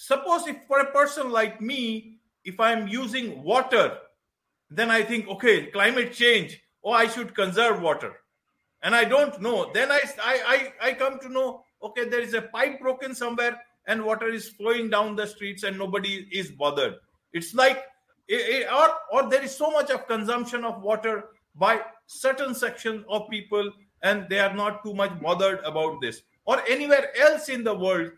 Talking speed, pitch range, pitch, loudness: 180 wpm, 205-260 Hz, 230 Hz, -24 LUFS